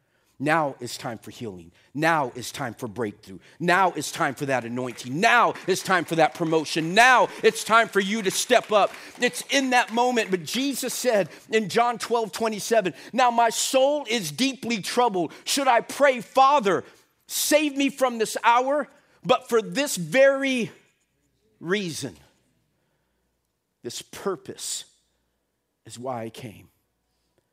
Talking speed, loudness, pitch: 145 wpm, -23 LUFS, 210 Hz